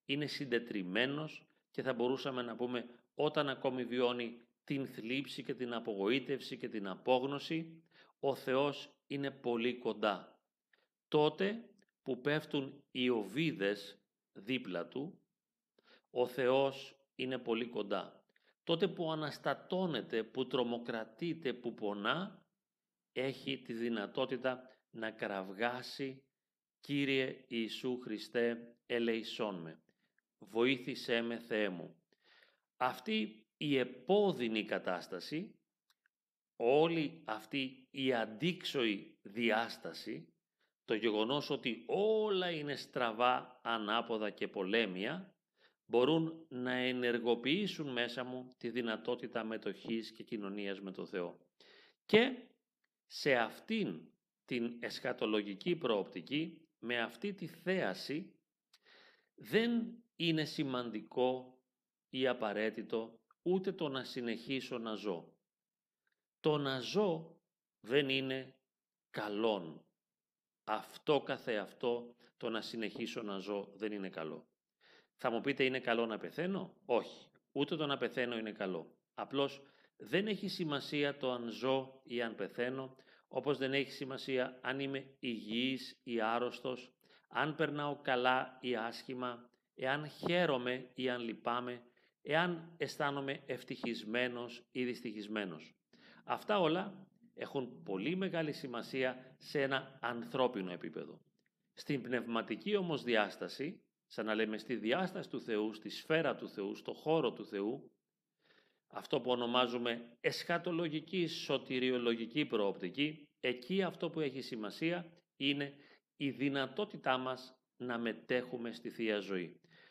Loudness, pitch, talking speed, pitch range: -38 LUFS, 130 Hz, 110 wpm, 115-150 Hz